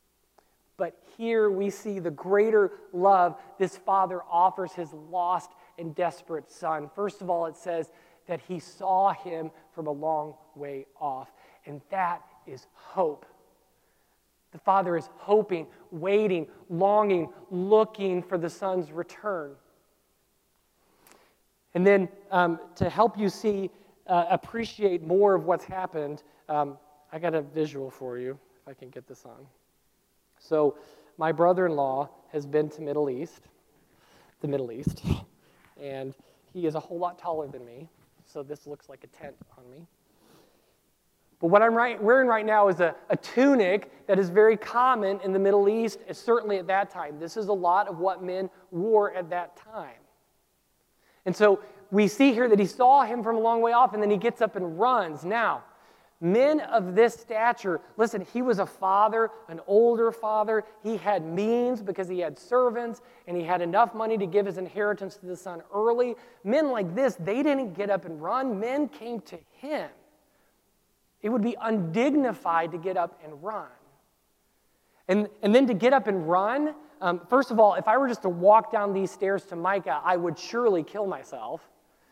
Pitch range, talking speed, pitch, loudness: 170-215 Hz, 170 wpm, 190 Hz, -26 LUFS